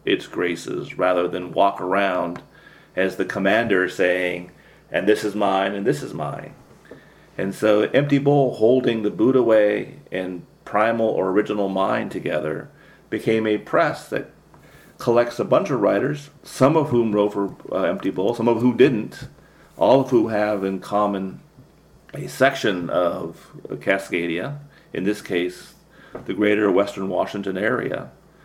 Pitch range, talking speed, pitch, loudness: 95-120 Hz, 150 wpm, 105 Hz, -21 LUFS